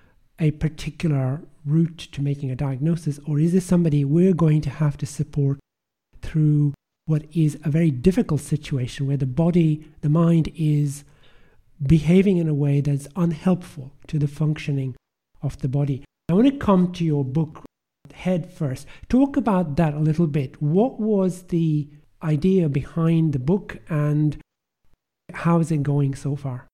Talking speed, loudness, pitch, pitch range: 160 wpm, -22 LUFS, 155 Hz, 145-170 Hz